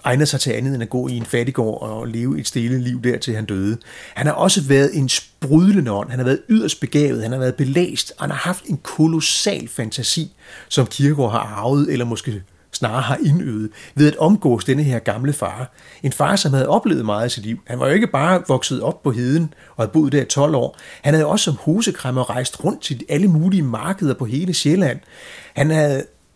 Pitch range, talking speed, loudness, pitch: 120-155 Hz, 225 wpm, -18 LUFS, 135 Hz